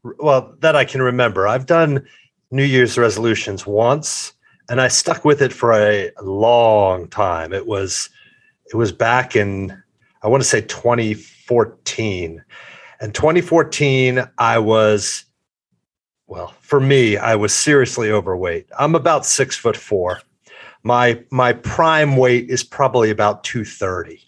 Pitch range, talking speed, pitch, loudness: 105-135 Hz, 135 wpm, 120 Hz, -16 LUFS